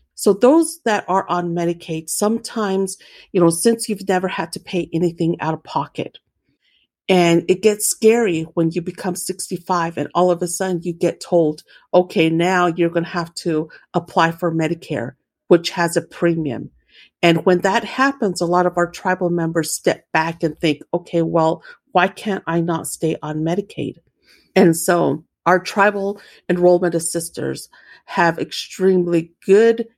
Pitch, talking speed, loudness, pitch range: 175 Hz, 160 wpm, -19 LUFS, 165-190 Hz